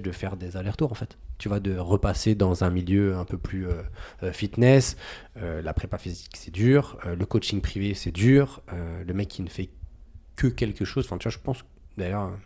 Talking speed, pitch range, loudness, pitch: 215 wpm, 90-105 Hz, -26 LUFS, 95 Hz